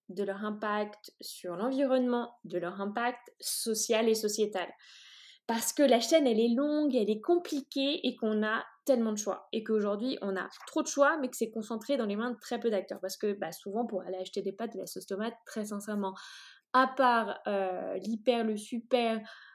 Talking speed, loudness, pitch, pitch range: 205 wpm, -31 LUFS, 225 Hz, 205-250 Hz